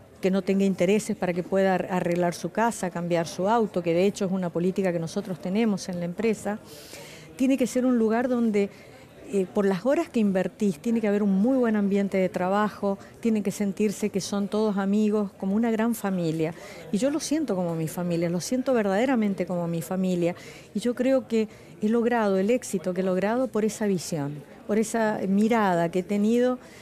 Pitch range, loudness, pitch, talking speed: 185-225 Hz, -25 LUFS, 200 Hz, 200 wpm